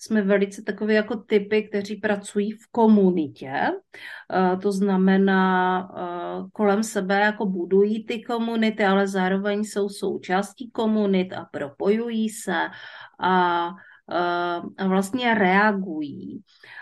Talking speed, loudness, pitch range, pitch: 105 wpm, -23 LUFS, 185-215 Hz, 200 Hz